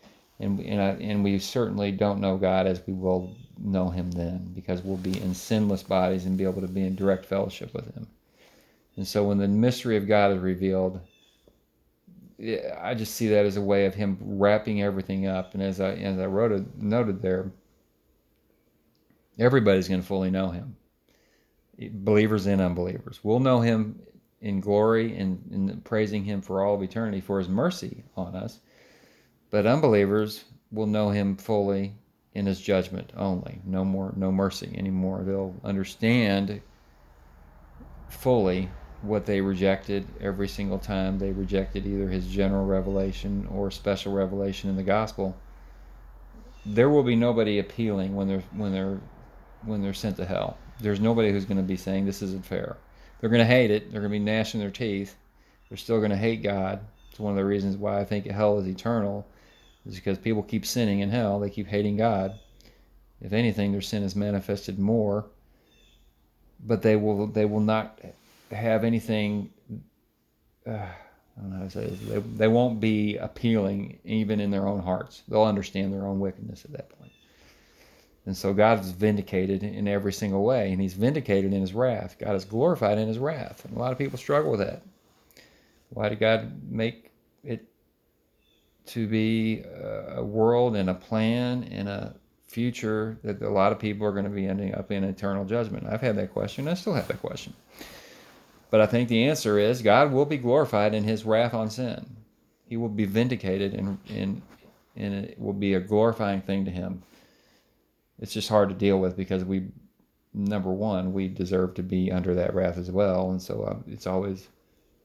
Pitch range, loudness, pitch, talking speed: 95-110 Hz, -26 LUFS, 100 Hz, 180 wpm